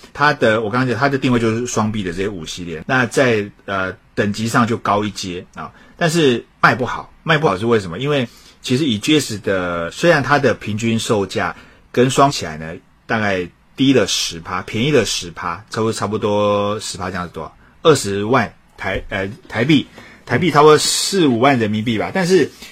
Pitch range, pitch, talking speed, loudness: 100-135 Hz, 110 Hz, 290 characters per minute, -17 LUFS